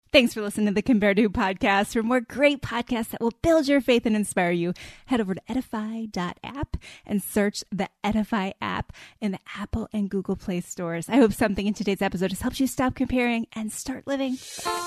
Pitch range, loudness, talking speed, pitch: 195-245 Hz, -25 LUFS, 200 wpm, 215 Hz